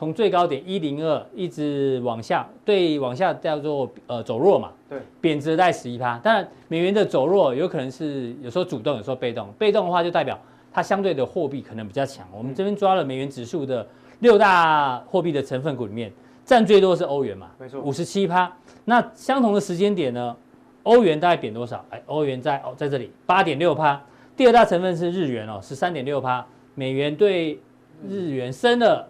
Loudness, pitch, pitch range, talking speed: -22 LUFS, 150 Hz, 130-185 Hz, 300 characters per minute